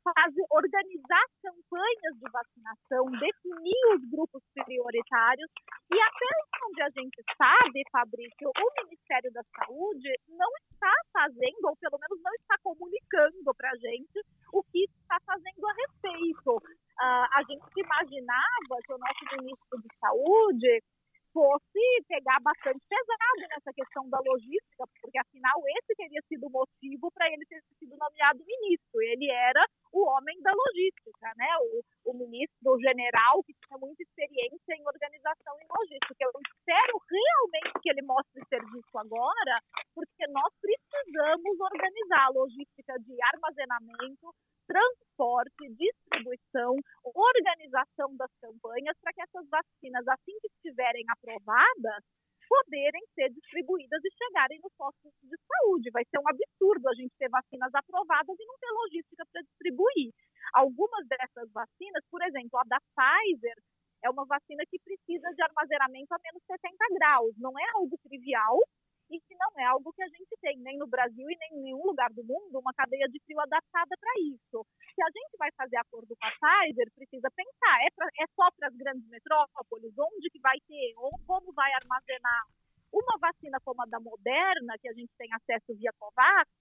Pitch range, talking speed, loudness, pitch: 260-370 Hz, 155 wpm, -29 LUFS, 300 Hz